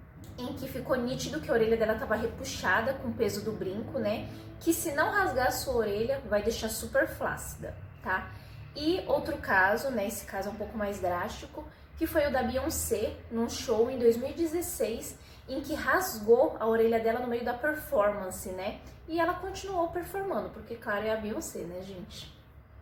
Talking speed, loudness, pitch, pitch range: 185 wpm, -30 LUFS, 245 Hz, 220-315 Hz